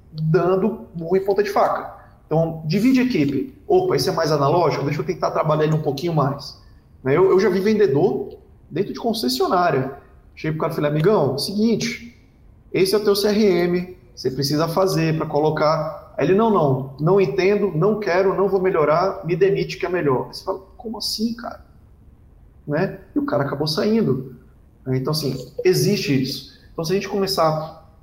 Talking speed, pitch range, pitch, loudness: 180 wpm, 150-205 Hz, 180 Hz, -20 LUFS